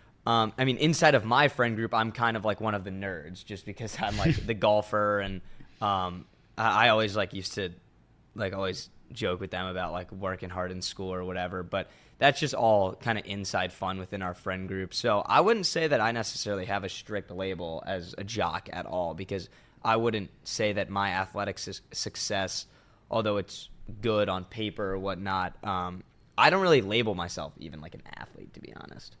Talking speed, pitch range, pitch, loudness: 205 wpm, 95-110 Hz, 100 Hz, -29 LUFS